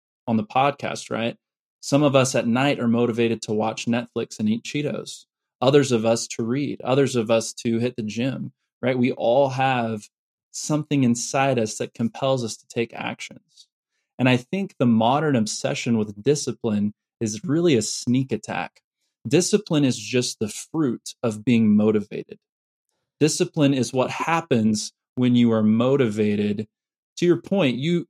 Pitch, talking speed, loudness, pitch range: 125 Hz, 160 wpm, -22 LUFS, 115-140 Hz